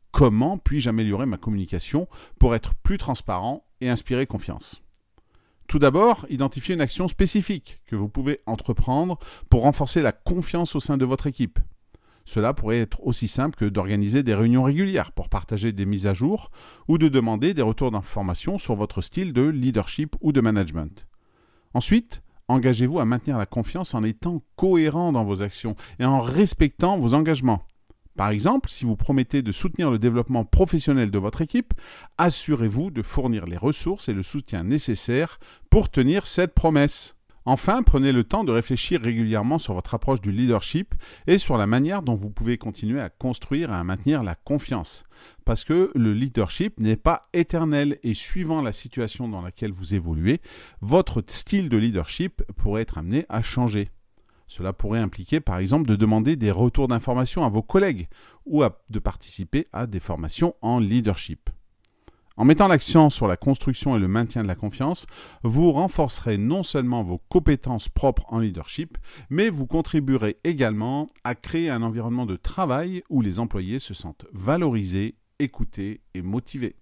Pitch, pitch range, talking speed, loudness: 120 Hz, 105-145 Hz, 170 wpm, -23 LUFS